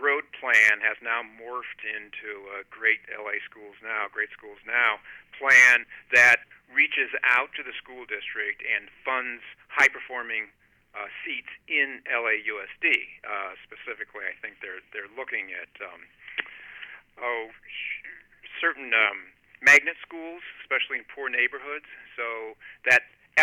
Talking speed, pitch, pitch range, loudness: 125 wpm, 115 Hz, 105-165 Hz, -23 LUFS